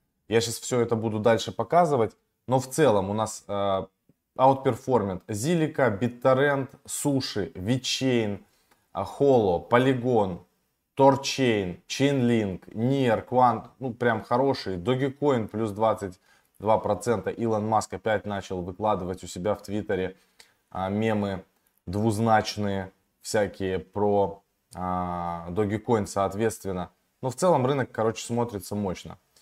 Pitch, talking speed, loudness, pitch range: 110 Hz, 110 wpm, -26 LUFS, 95-125 Hz